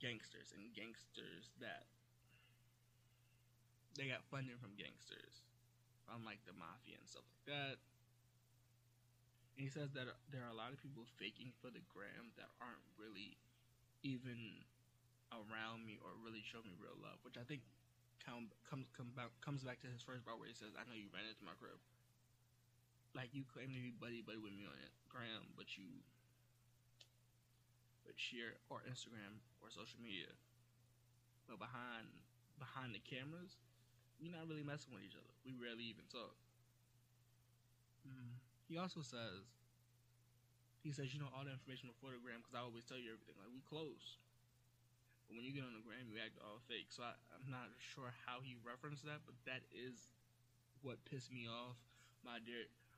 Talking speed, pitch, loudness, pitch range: 175 wpm, 120 Hz, -54 LUFS, 120-125 Hz